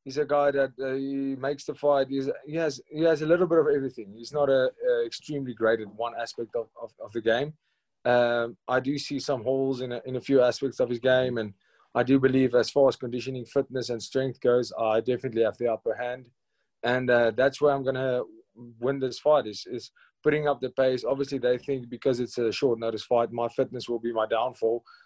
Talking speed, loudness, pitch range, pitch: 230 wpm, -27 LUFS, 120-140 Hz, 130 Hz